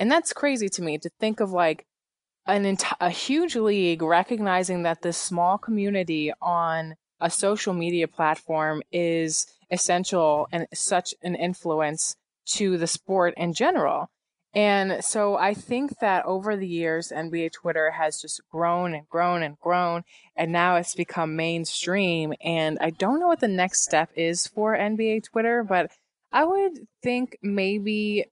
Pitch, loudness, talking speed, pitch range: 175 Hz, -25 LUFS, 155 wpm, 165-205 Hz